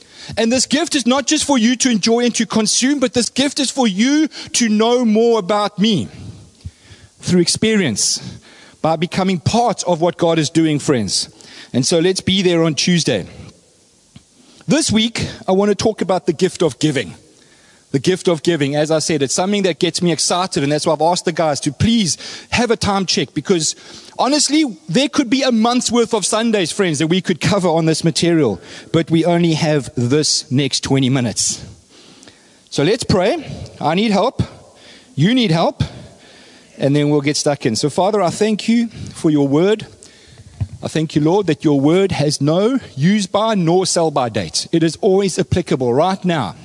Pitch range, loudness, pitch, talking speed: 155-220 Hz, -16 LUFS, 180 Hz, 190 wpm